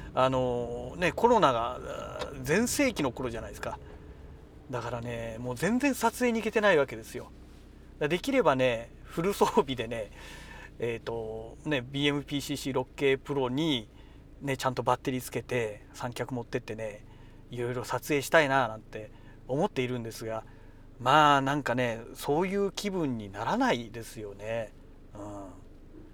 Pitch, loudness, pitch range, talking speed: 125 Hz, -29 LUFS, 110-140 Hz, 300 characters per minute